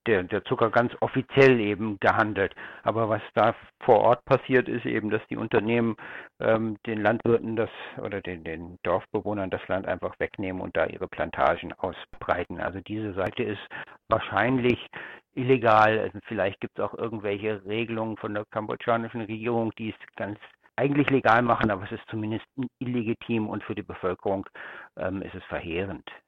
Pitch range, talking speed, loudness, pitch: 105-120 Hz, 160 wpm, -27 LUFS, 110 Hz